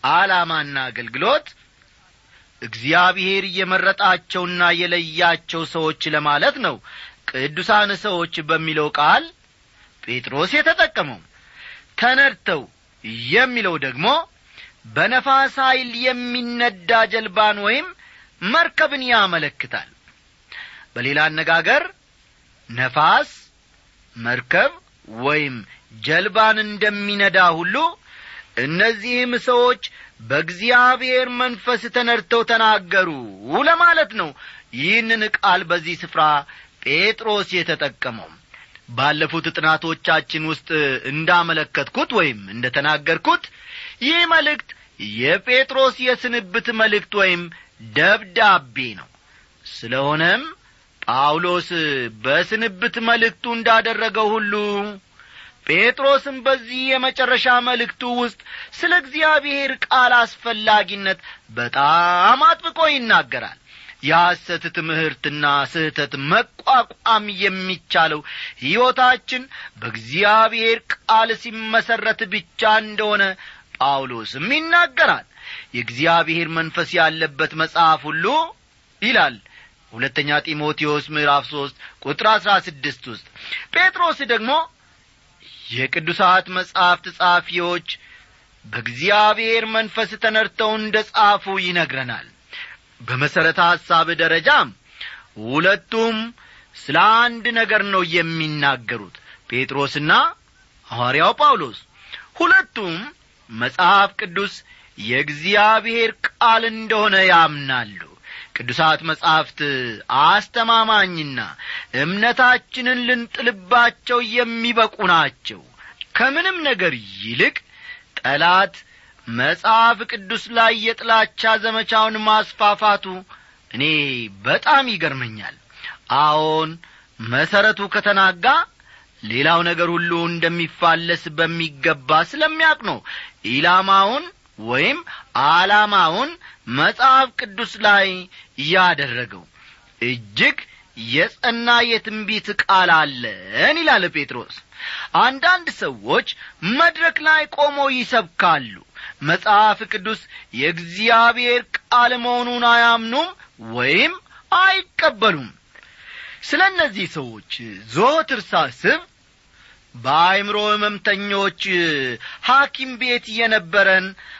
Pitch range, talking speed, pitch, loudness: 160-240 Hz, 75 wpm, 205 Hz, -17 LUFS